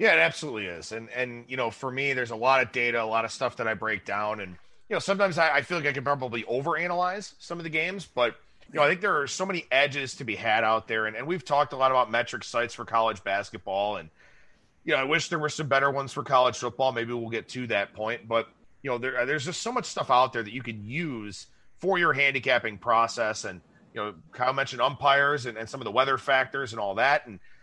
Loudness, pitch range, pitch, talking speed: -27 LUFS, 115-145 Hz, 130 Hz, 265 wpm